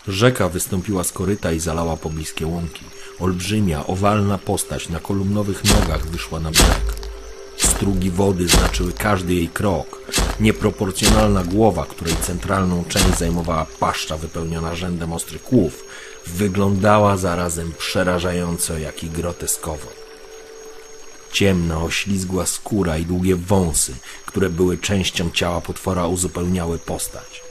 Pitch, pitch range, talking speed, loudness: 90 Hz, 85-100 Hz, 115 wpm, -20 LUFS